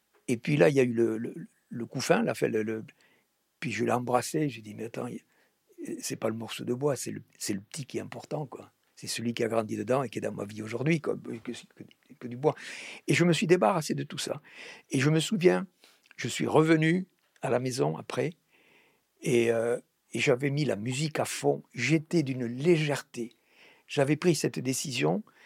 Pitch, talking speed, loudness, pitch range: 130 Hz, 215 wpm, -29 LUFS, 115-160 Hz